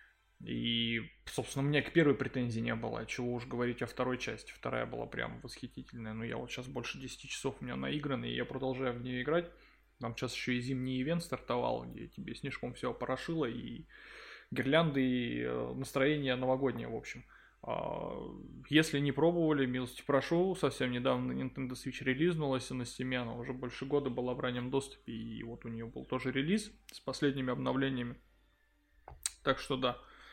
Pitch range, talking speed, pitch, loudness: 120-140 Hz, 175 wpm, 130 Hz, -36 LUFS